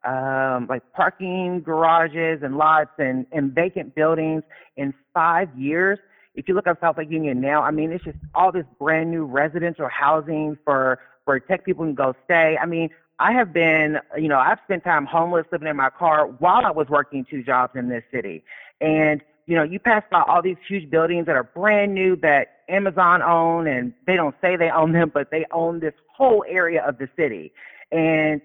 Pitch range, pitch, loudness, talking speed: 145-175 Hz, 160 Hz, -20 LUFS, 205 wpm